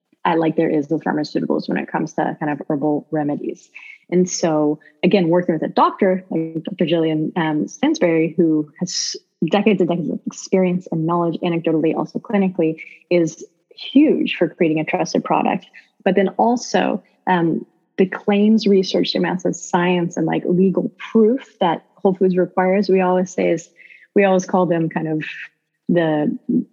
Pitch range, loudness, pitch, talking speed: 160-195 Hz, -19 LUFS, 180 Hz, 165 wpm